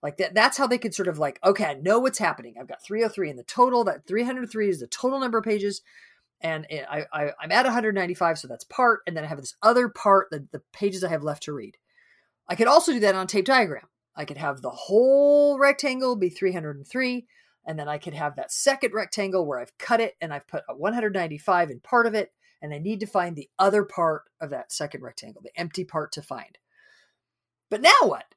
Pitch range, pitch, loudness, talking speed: 155-240 Hz, 195 Hz, -24 LUFS, 235 wpm